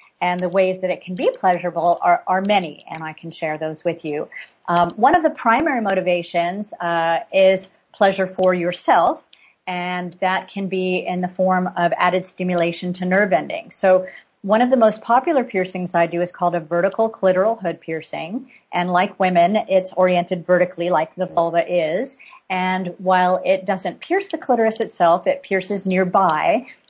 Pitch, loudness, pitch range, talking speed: 185 Hz, -19 LUFS, 175-195 Hz, 175 wpm